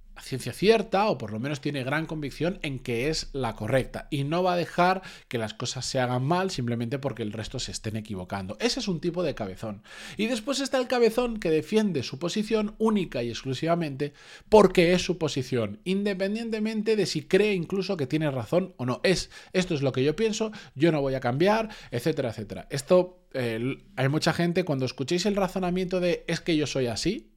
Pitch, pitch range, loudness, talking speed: 160 Hz, 130-190 Hz, -27 LUFS, 205 wpm